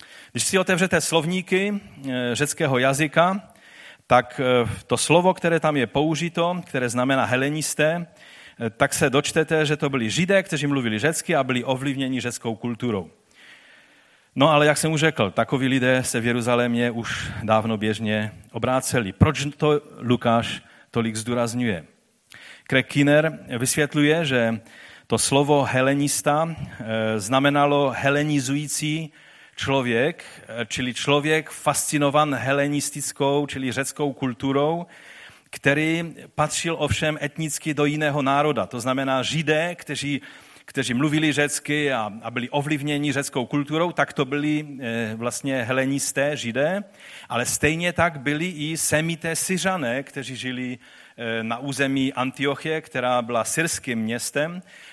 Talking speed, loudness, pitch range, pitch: 120 wpm, -22 LUFS, 125-155 Hz, 140 Hz